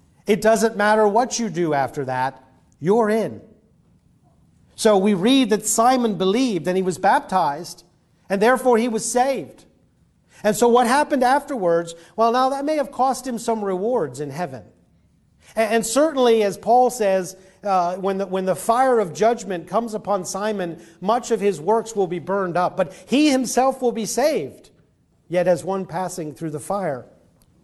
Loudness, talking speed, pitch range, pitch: -20 LUFS, 170 wpm, 185-240 Hz, 210 Hz